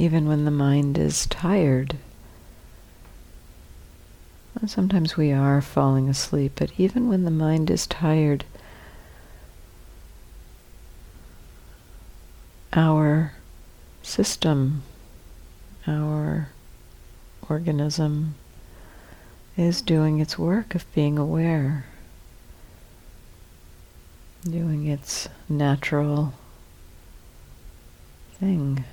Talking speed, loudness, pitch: 70 wpm, -23 LUFS, 140 Hz